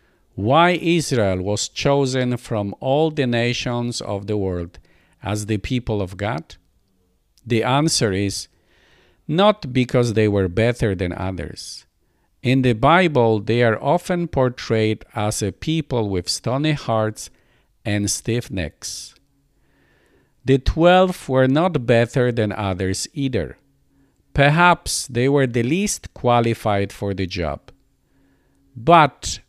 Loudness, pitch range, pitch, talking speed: -20 LUFS, 95-135 Hz, 115 Hz, 120 wpm